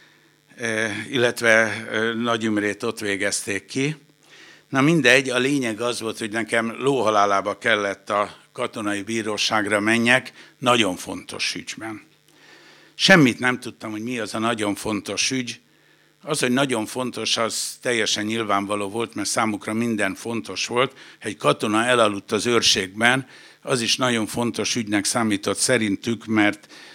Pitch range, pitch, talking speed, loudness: 105-125 Hz, 115 Hz, 130 wpm, -21 LUFS